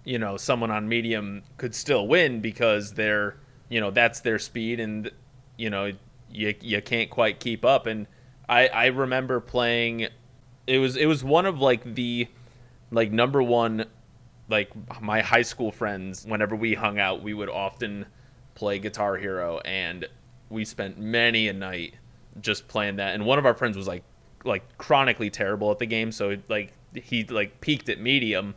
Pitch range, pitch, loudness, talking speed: 105-125 Hz, 115 Hz, -25 LUFS, 180 wpm